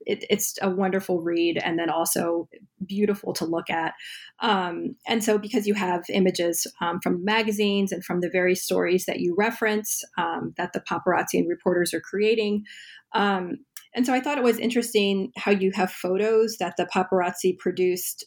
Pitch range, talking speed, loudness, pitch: 180-215 Hz, 175 wpm, -25 LUFS, 195 Hz